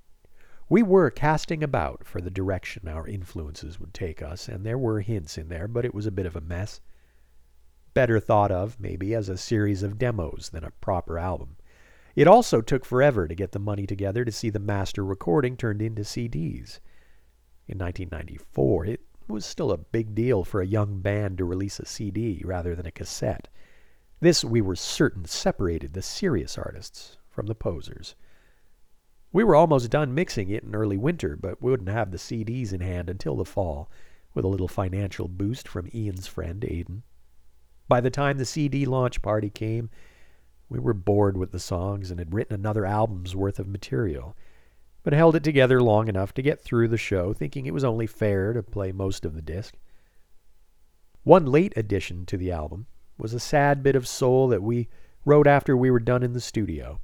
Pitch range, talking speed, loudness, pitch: 90-120 Hz, 190 wpm, -25 LUFS, 100 Hz